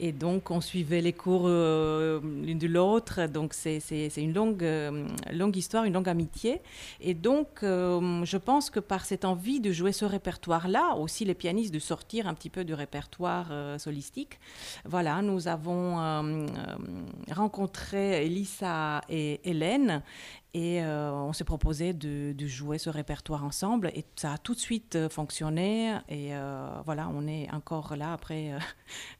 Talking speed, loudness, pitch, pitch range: 170 wpm, -31 LUFS, 170 Hz, 155-190 Hz